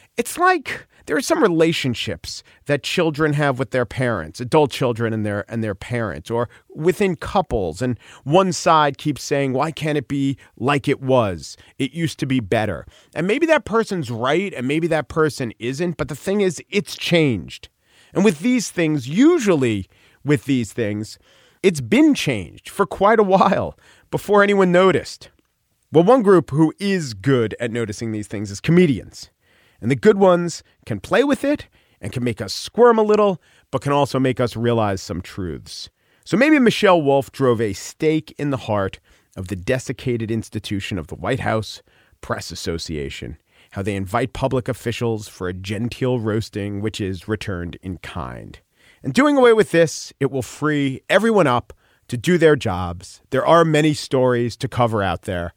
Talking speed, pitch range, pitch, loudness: 175 wpm, 110-165 Hz, 130 Hz, -19 LUFS